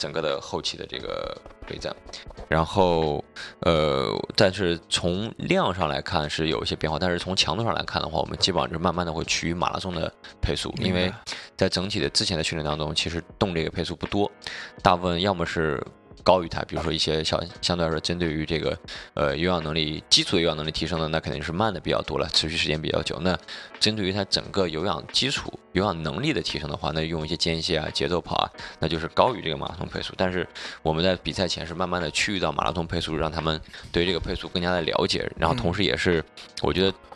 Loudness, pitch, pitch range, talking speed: -25 LUFS, 85 Hz, 80-90 Hz, 350 characters per minute